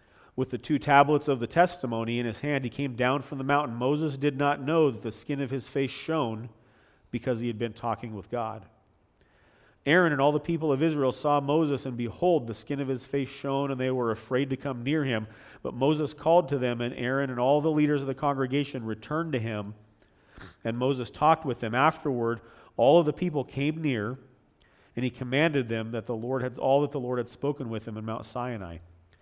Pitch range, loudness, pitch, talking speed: 115-145 Hz, -28 LUFS, 130 Hz, 220 wpm